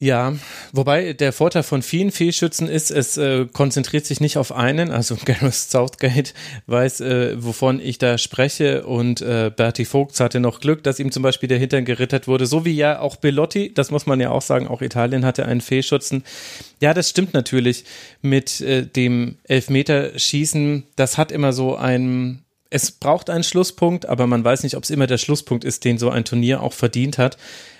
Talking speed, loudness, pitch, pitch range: 190 wpm, -19 LUFS, 135 Hz, 125-145 Hz